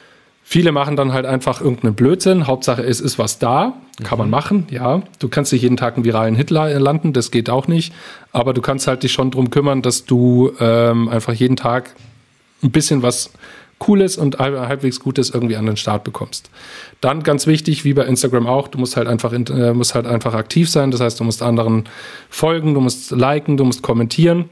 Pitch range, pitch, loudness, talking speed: 120-145 Hz, 130 Hz, -16 LUFS, 205 wpm